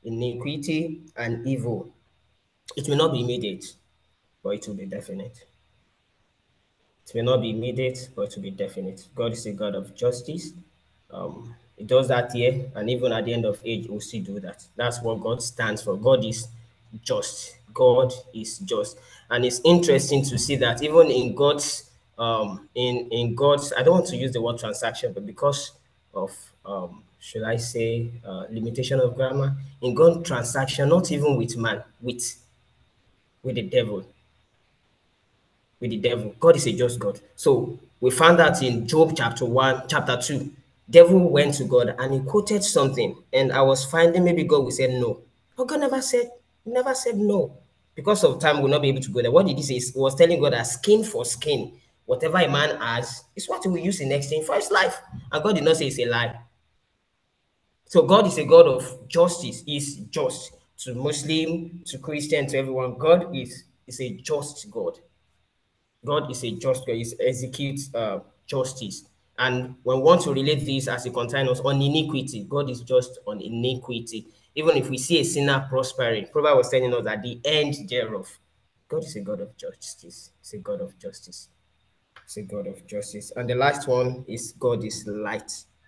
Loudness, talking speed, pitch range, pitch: -23 LUFS, 190 wpm, 120-155 Hz, 130 Hz